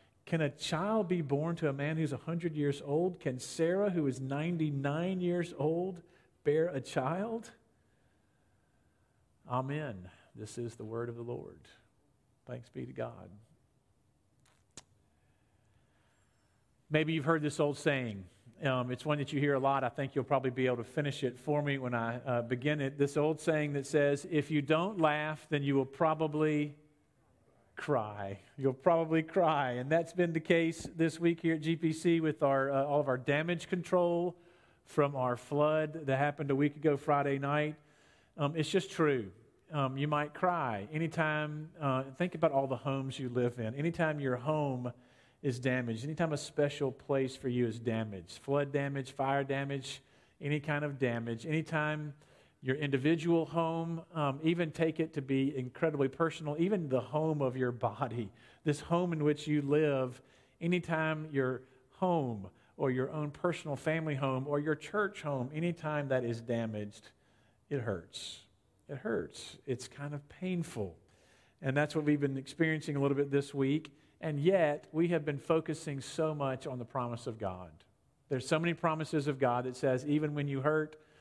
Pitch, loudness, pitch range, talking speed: 145 Hz, -34 LUFS, 130-160 Hz, 170 wpm